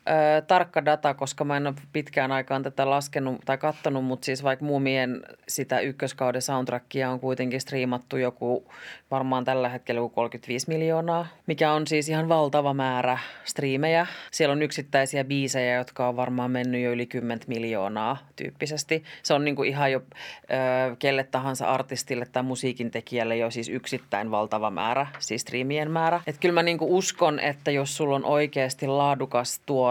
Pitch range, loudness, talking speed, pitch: 125-150 Hz, -26 LUFS, 170 wpm, 135 Hz